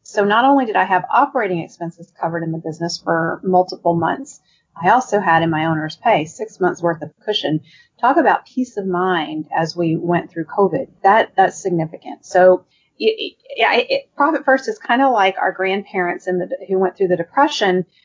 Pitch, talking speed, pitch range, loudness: 185 Hz, 200 wpm, 170-215 Hz, -18 LUFS